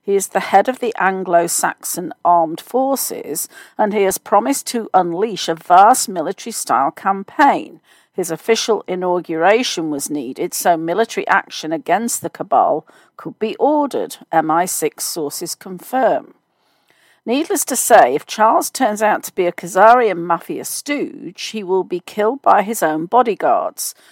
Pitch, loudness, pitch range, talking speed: 200 Hz, -17 LUFS, 175-235 Hz, 145 wpm